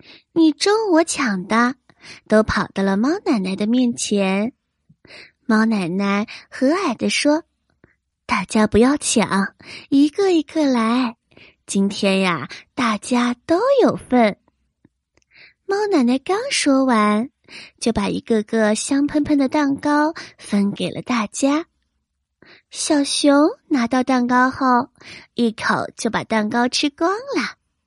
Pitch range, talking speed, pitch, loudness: 215-295 Hz, 170 characters per minute, 250 Hz, -19 LUFS